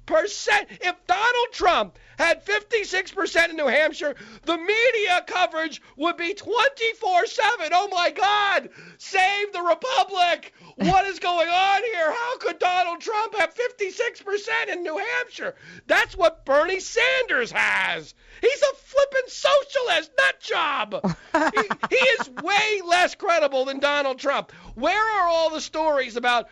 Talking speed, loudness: 140 wpm, -22 LUFS